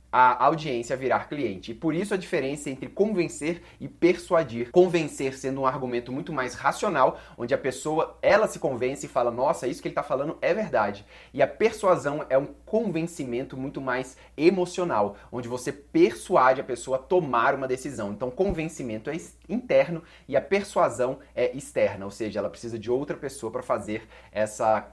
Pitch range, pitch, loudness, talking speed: 125-170 Hz, 140 Hz, -26 LUFS, 175 wpm